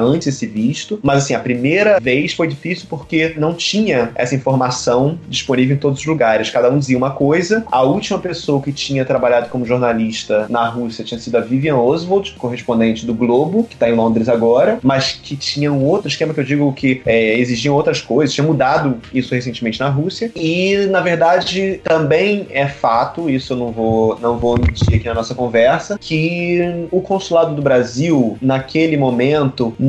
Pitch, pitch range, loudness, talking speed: 140 Hz, 120-165 Hz, -16 LUFS, 185 wpm